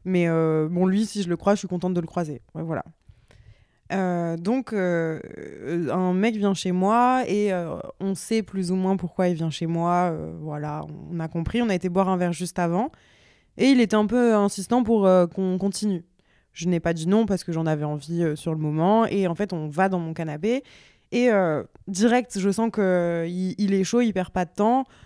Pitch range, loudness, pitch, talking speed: 170-205 Hz, -24 LUFS, 185 Hz, 230 wpm